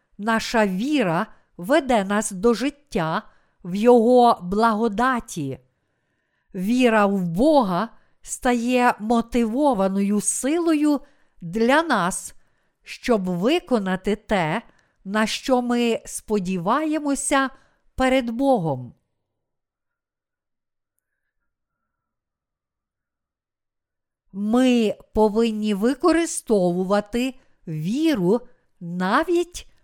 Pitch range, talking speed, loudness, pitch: 185-255 Hz, 60 wpm, -21 LUFS, 225 Hz